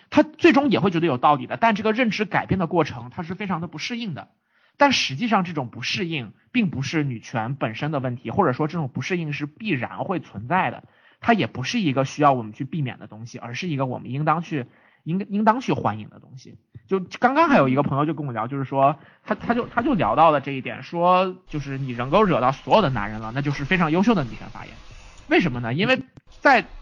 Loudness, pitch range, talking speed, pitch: -22 LUFS, 130-190 Hz, 355 characters per minute, 150 Hz